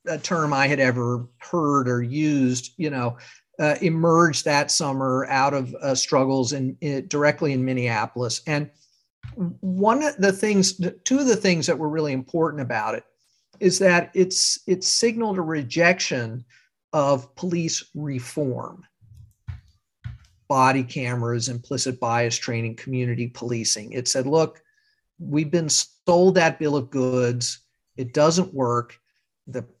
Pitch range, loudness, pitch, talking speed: 125-170 Hz, -22 LUFS, 140 Hz, 140 wpm